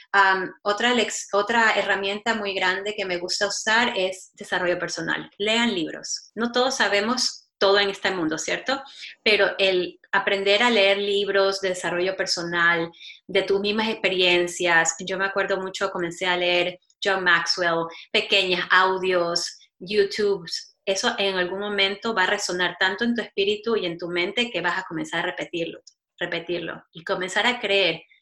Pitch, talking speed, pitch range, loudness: 195 Hz, 155 wpm, 180-205 Hz, -22 LUFS